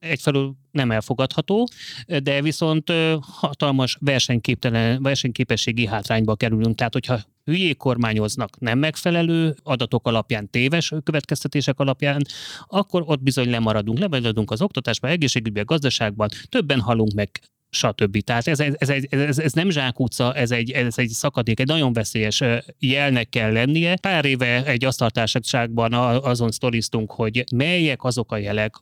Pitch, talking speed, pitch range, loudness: 130 Hz, 135 wpm, 115-145 Hz, -21 LUFS